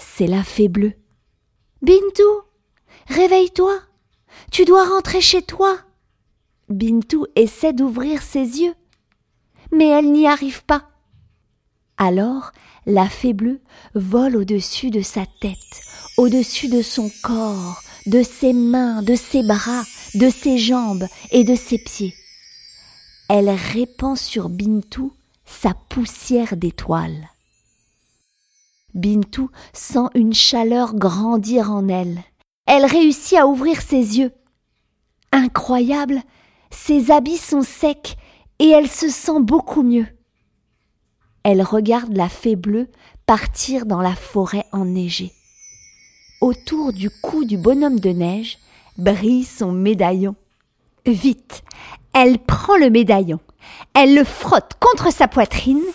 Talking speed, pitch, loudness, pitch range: 115 wpm, 245 Hz, -16 LUFS, 205-280 Hz